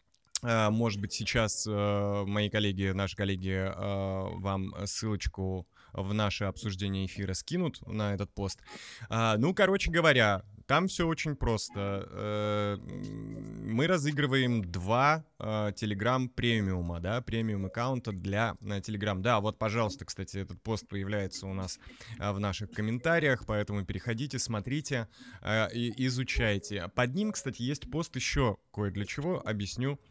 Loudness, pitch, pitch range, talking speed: -31 LUFS, 105 Hz, 100-125 Hz, 135 wpm